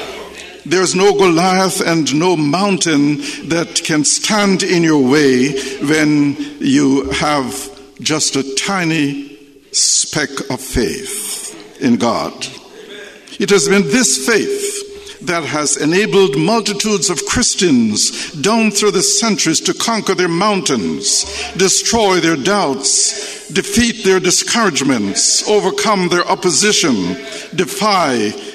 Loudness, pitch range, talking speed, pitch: -13 LUFS, 155-210 Hz, 110 wpm, 190 Hz